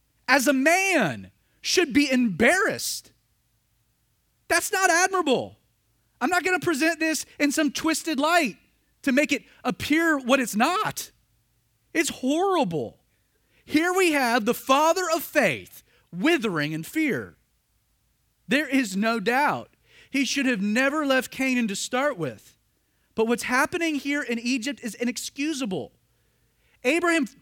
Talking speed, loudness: 130 wpm, -24 LUFS